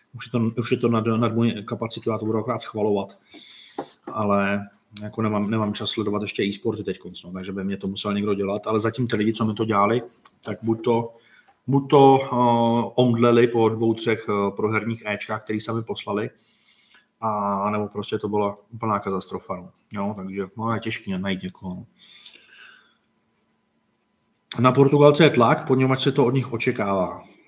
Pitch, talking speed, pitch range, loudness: 110 Hz, 170 wpm, 105-115 Hz, -22 LUFS